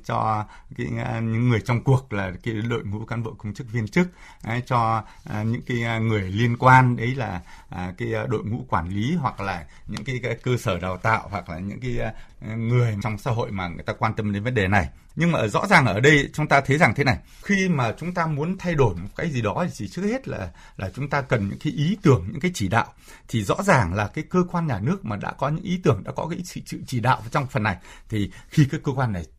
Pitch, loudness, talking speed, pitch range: 120 Hz, -23 LUFS, 260 wpm, 105-140 Hz